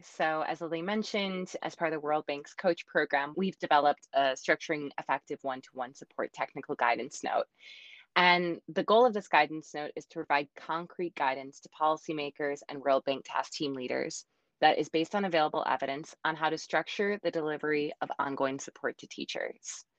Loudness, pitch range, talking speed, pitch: -31 LUFS, 145-170 Hz, 185 wpm, 155 Hz